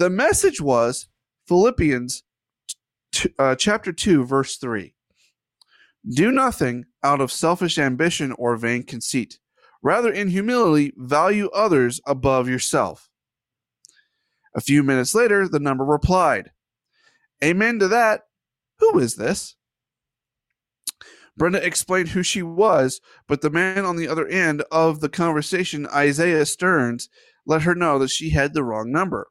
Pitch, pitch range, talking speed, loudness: 155 Hz, 135-185 Hz, 135 wpm, -20 LUFS